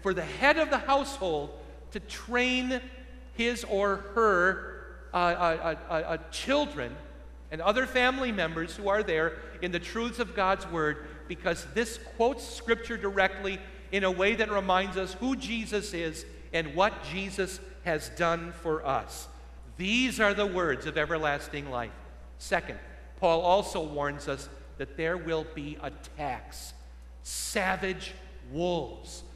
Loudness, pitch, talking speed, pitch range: -29 LUFS, 180 Hz, 140 wpm, 155-210 Hz